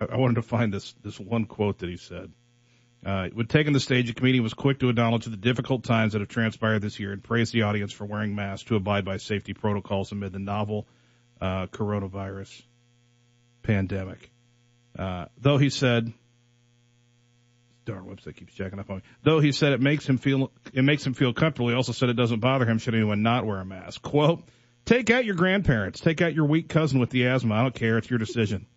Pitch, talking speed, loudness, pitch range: 120 Hz, 215 wpm, -25 LUFS, 105-125 Hz